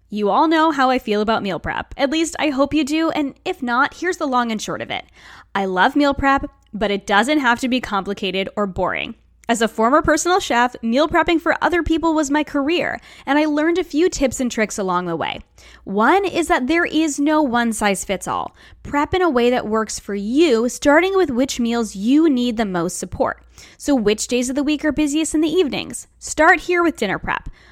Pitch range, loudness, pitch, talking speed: 220-315 Hz, -18 LUFS, 275 Hz, 225 wpm